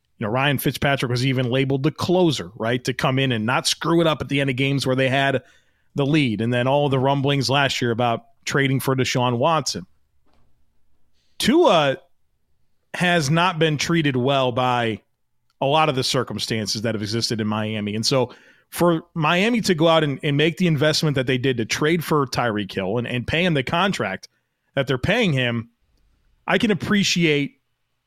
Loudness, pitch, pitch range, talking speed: -20 LUFS, 135 Hz, 115-155 Hz, 190 wpm